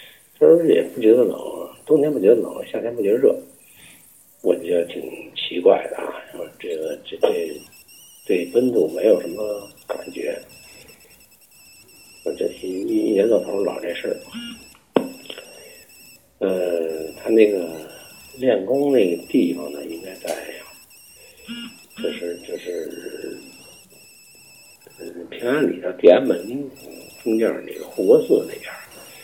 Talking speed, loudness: 180 characters per minute, -21 LUFS